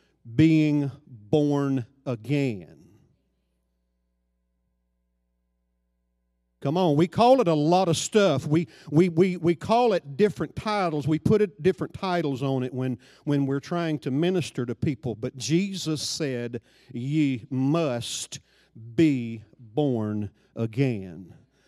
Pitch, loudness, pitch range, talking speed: 140 Hz, -25 LUFS, 115-160 Hz, 120 wpm